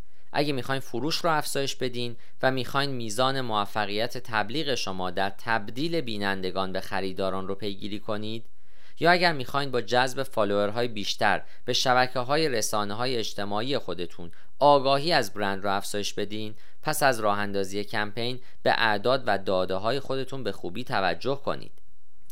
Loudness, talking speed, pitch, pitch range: -27 LUFS, 145 wpm, 115 Hz, 100-135 Hz